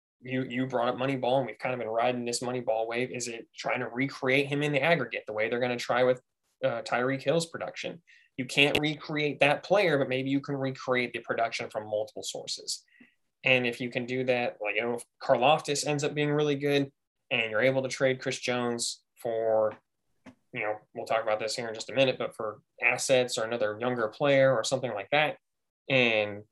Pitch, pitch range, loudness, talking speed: 125 Hz, 120-135 Hz, -28 LUFS, 220 wpm